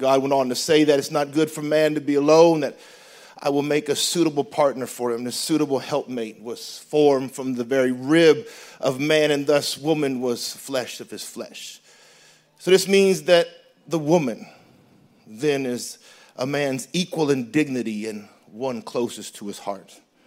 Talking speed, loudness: 180 wpm, -21 LUFS